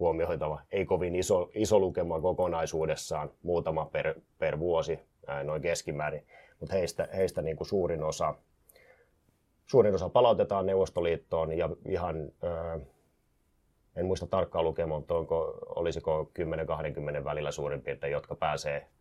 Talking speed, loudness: 125 wpm, -31 LUFS